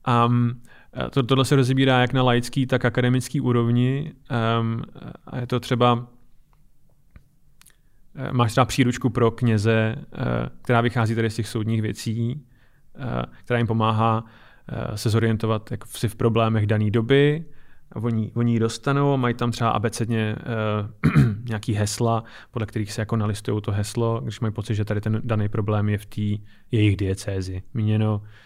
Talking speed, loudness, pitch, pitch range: 150 wpm, -23 LUFS, 115 Hz, 110-125 Hz